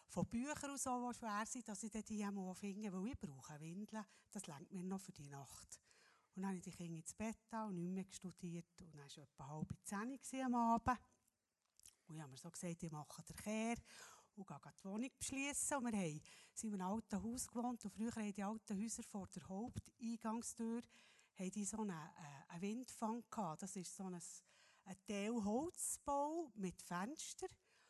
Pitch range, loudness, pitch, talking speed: 175-230 Hz, -47 LUFS, 200 Hz, 180 wpm